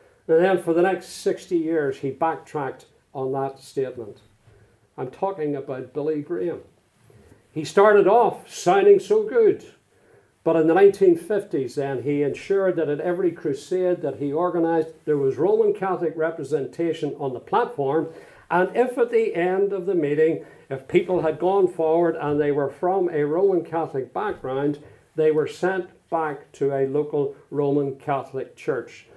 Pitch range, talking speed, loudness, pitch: 145-185 Hz, 155 wpm, -22 LUFS, 160 Hz